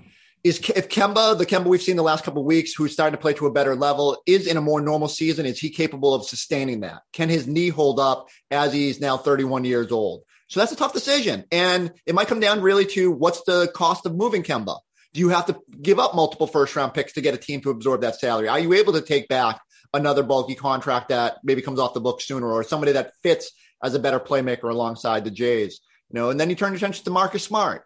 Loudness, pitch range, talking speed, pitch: -22 LUFS, 135-180 Hz, 250 wpm, 150 Hz